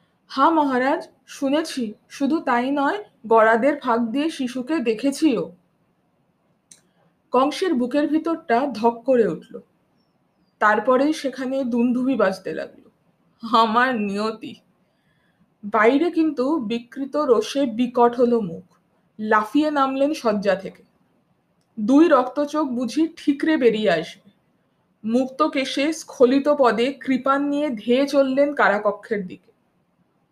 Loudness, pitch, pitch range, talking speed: -21 LUFS, 255 Hz, 225-290 Hz, 100 wpm